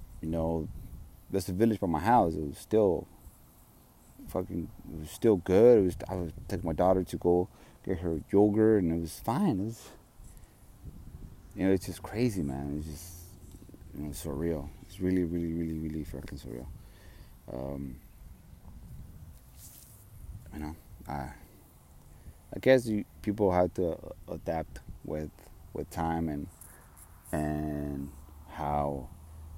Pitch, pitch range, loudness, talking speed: 85 Hz, 75-95 Hz, -30 LUFS, 140 wpm